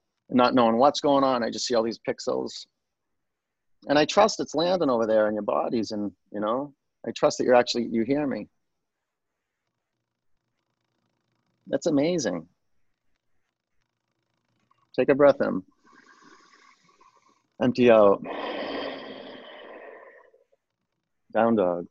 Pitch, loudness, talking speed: 145 Hz, -24 LUFS, 115 wpm